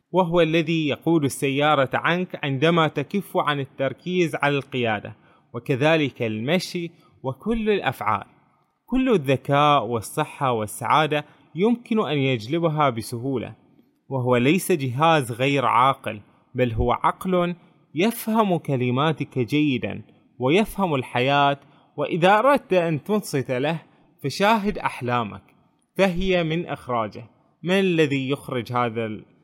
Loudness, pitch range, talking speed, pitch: -22 LUFS, 130-175 Hz, 100 wpm, 150 Hz